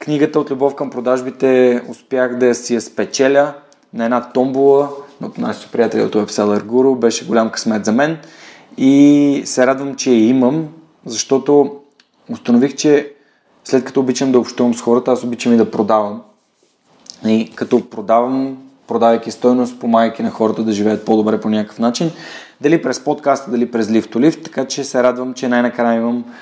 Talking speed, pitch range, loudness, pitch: 170 wpm, 115-140 Hz, -15 LUFS, 125 Hz